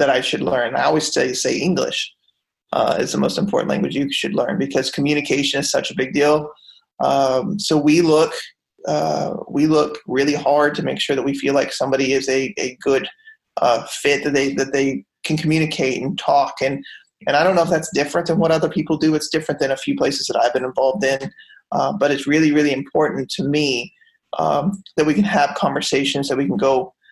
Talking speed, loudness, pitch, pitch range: 215 wpm, -19 LUFS, 145 Hz, 135-155 Hz